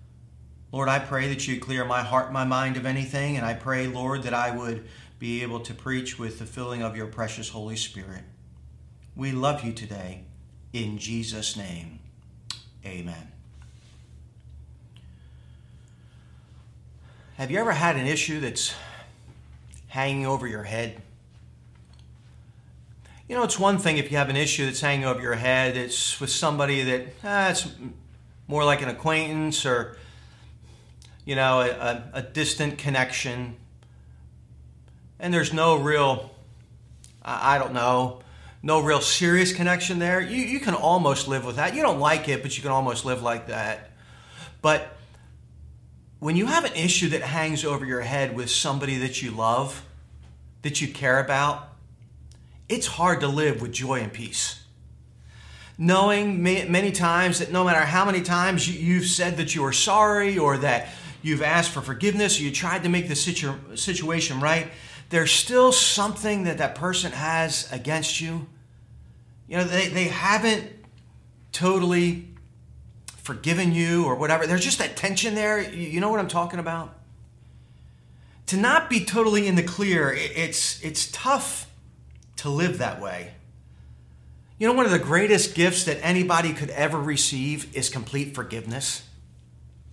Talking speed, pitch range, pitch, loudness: 155 wpm, 110-165 Hz, 135 Hz, -24 LUFS